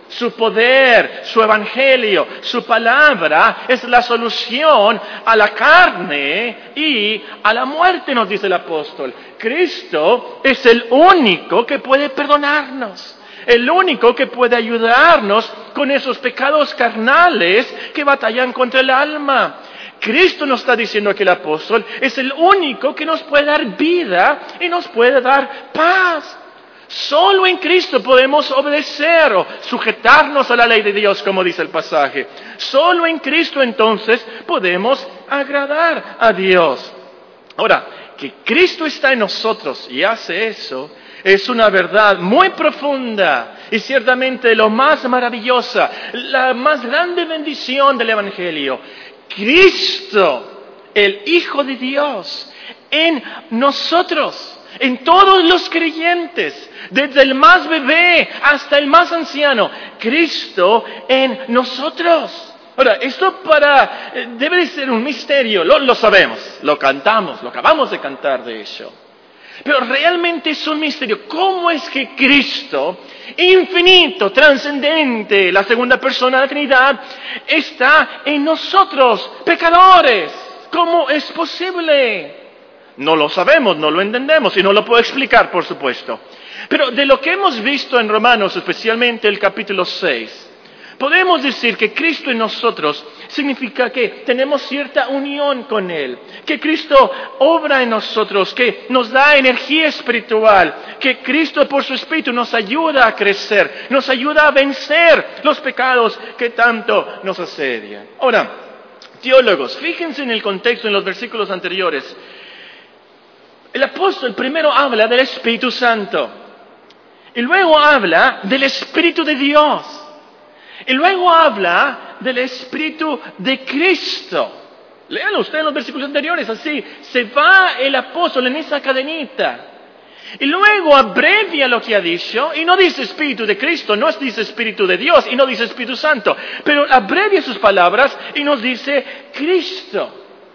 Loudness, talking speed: -13 LUFS, 135 wpm